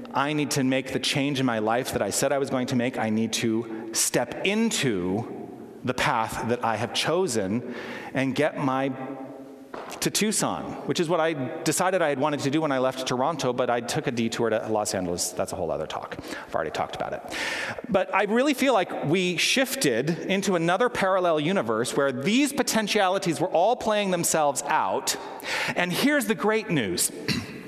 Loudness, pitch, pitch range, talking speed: -25 LUFS, 150 Hz, 130-190 Hz, 195 wpm